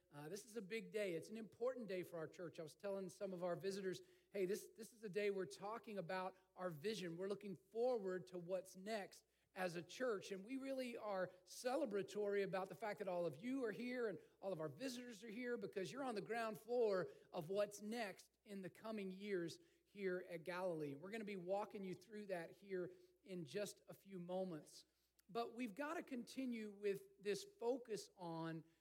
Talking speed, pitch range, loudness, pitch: 210 wpm, 185-225 Hz, -48 LUFS, 200 Hz